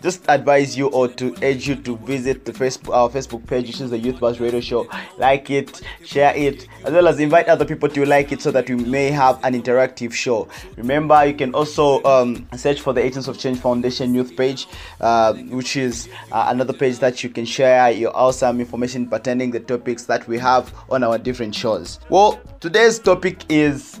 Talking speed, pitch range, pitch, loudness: 210 wpm, 120-140 Hz, 130 Hz, -18 LUFS